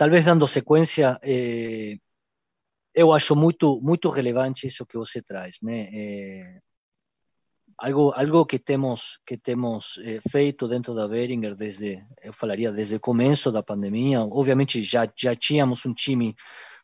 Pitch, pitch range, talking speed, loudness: 125 Hz, 110-140 Hz, 135 wpm, -23 LUFS